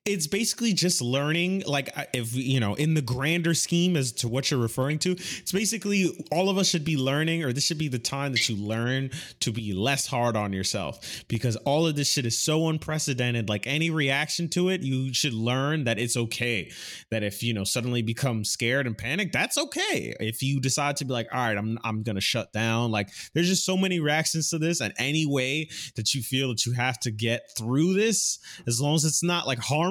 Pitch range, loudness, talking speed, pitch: 120-160 Hz, -26 LUFS, 225 wpm, 135 Hz